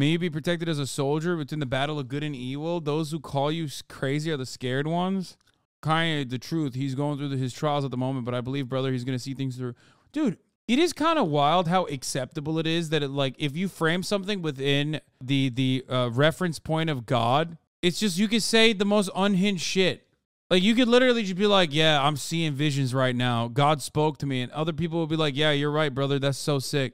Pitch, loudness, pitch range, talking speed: 150 Hz, -25 LUFS, 135-170 Hz, 240 wpm